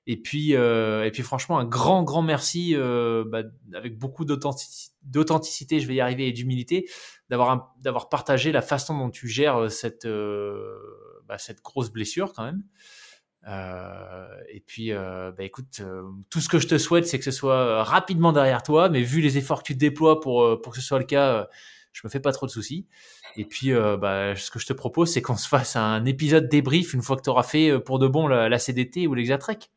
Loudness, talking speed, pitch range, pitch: -23 LUFS, 220 wpm, 115-155 Hz, 130 Hz